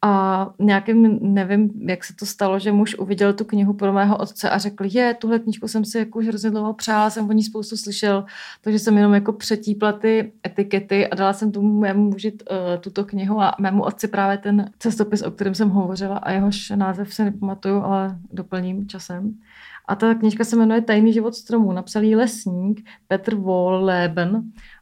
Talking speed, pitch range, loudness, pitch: 185 wpm, 195-220 Hz, -20 LUFS, 205 Hz